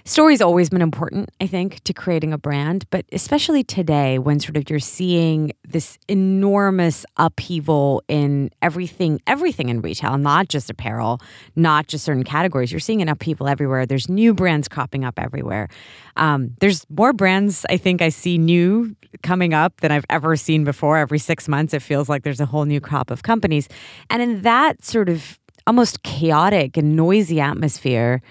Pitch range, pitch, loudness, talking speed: 145-185 Hz, 160 Hz, -19 LUFS, 175 wpm